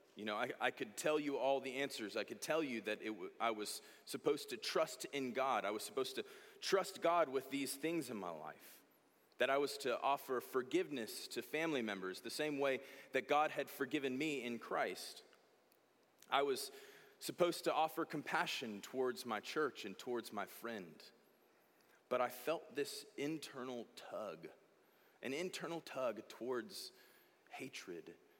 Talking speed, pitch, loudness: 165 wpm, 150 Hz, -41 LUFS